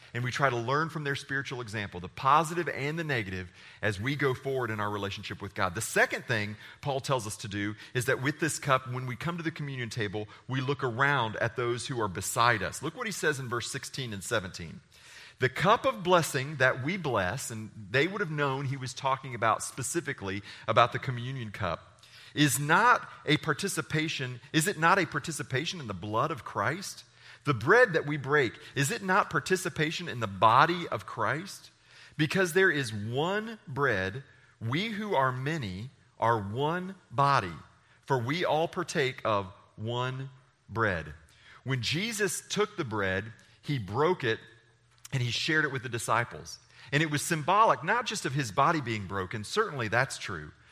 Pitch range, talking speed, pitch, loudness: 115-150 Hz, 185 wpm, 130 Hz, -29 LUFS